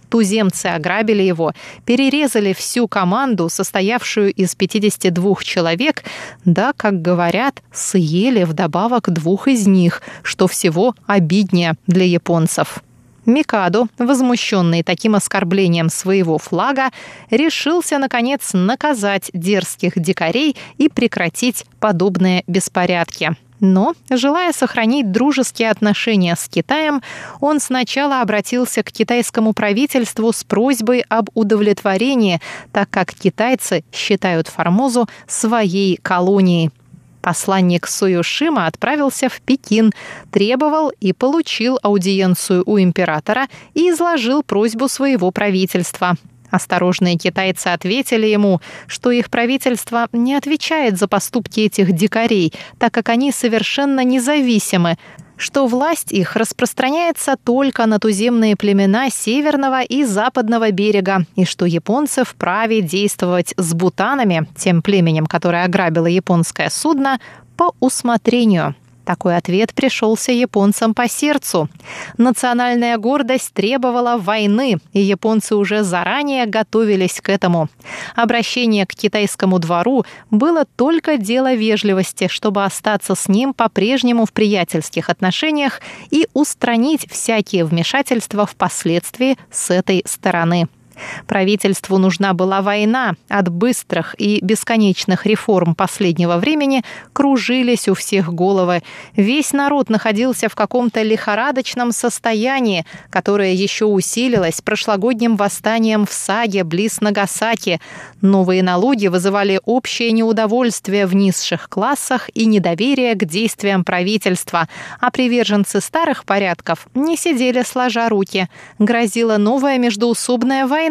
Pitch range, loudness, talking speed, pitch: 185-245 Hz, -16 LUFS, 110 wpm, 210 Hz